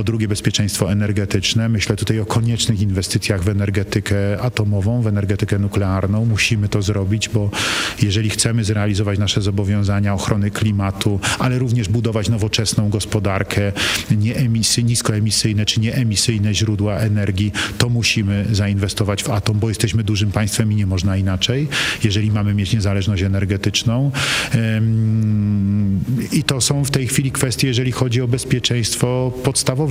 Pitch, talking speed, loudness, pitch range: 110 Hz, 135 wpm, -18 LUFS, 105-115 Hz